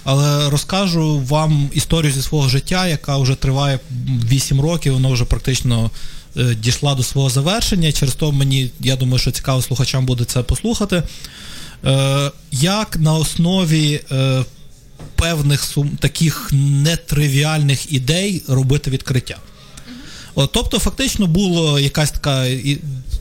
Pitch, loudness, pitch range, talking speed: 140 Hz, -17 LUFS, 130-155 Hz, 130 wpm